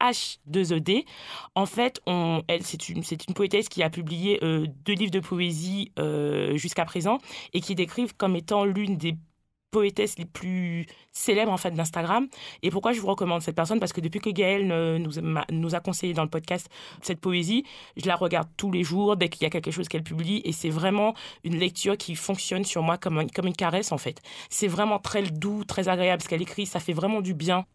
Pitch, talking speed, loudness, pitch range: 180 Hz, 220 wpm, -27 LUFS, 165-200 Hz